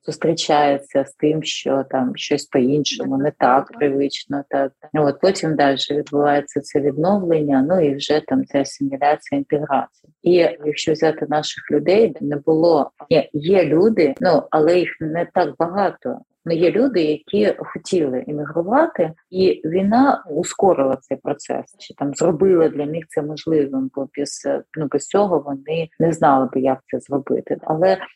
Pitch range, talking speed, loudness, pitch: 140-165 Hz, 150 wpm, -19 LUFS, 150 Hz